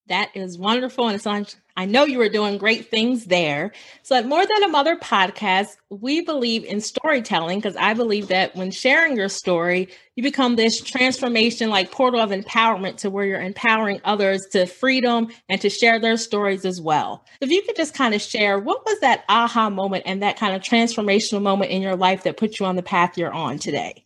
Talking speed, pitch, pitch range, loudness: 210 wpm, 210 Hz, 190-240 Hz, -20 LUFS